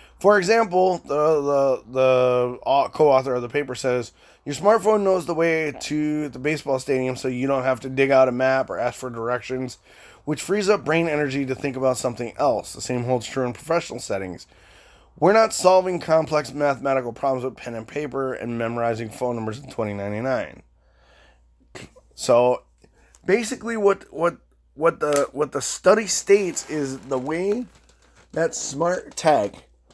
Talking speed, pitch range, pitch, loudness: 165 wpm, 125-165 Hz, 135 Hz, -22 LUFS